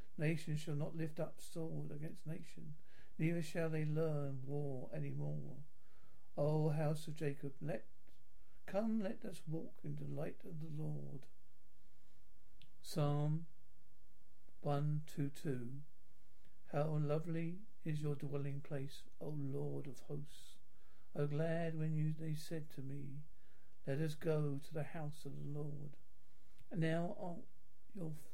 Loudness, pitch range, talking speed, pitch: -43 LUFS, 140-160 Hz, 145 wpm, 150 Hz